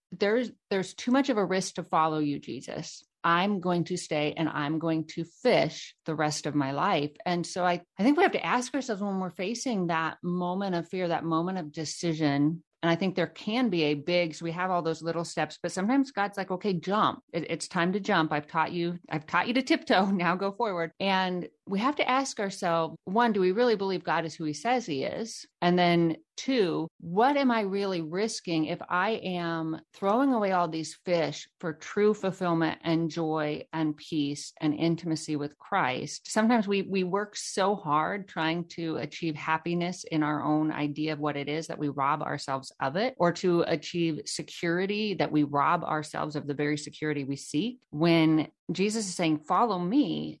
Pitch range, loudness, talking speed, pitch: 160-195 Hz, -29 LUFS, 205 wpm, 170 Hz